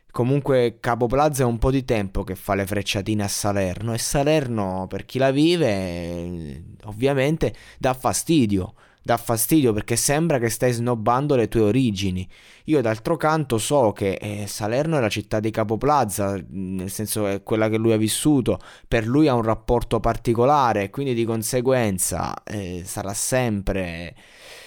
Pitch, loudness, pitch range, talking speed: 110 Hz, -22 LUFS, 100-130 Hz, 160 wpm